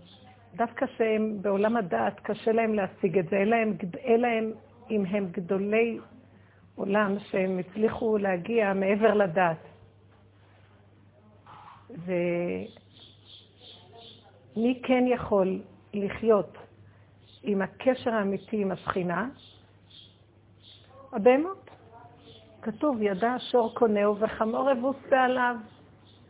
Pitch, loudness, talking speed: 200 Hz, -27 LUFS, 85 wpm